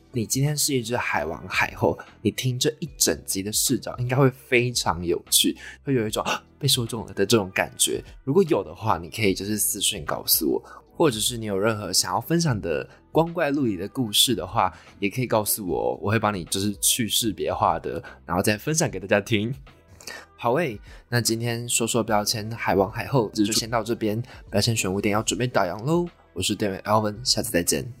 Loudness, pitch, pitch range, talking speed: -23 LUFS, 110 Hz, 100-125 Hz, 310 characters per minute